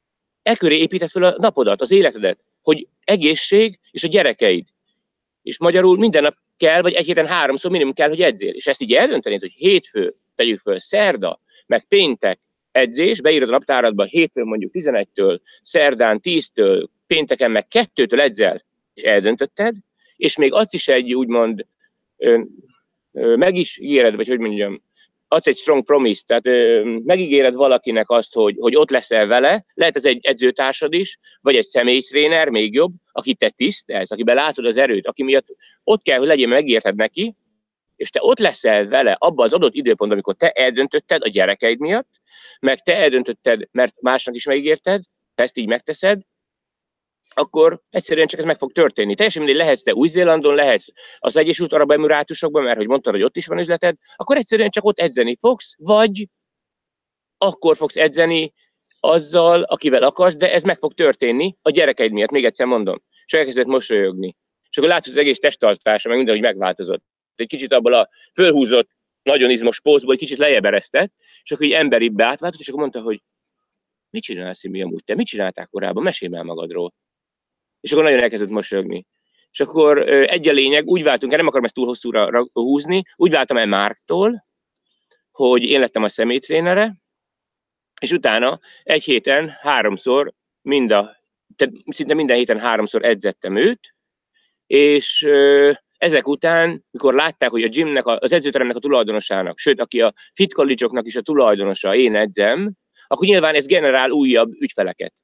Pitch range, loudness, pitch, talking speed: 135-230 Hz, -16 LUFS, 170 Hz, 165 wpm